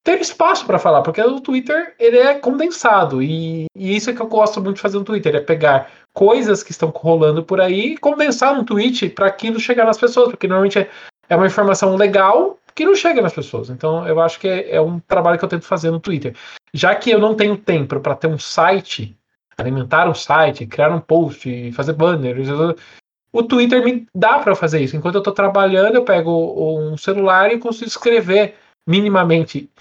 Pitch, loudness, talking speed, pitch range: 195 Hz, -15 LUFS, 205 wpm, 160-230 Hz